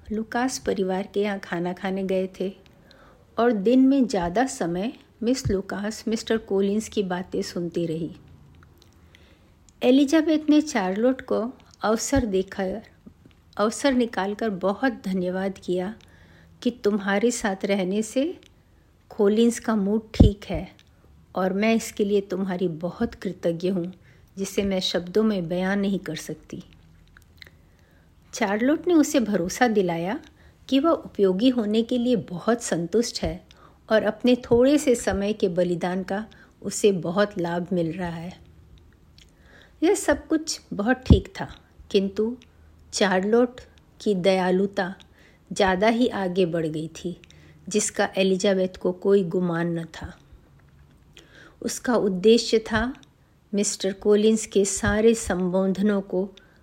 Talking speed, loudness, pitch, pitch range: 125 wpm, -24 LUFS, 200 Hz, 180-225 Hz